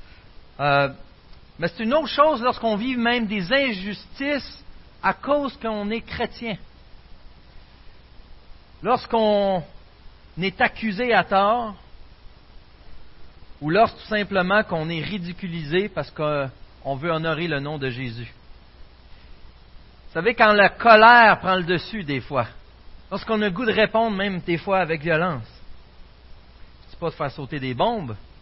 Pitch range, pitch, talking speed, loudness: 140-220 Hz, 185 Hz, 135 wpm, -21 LUFS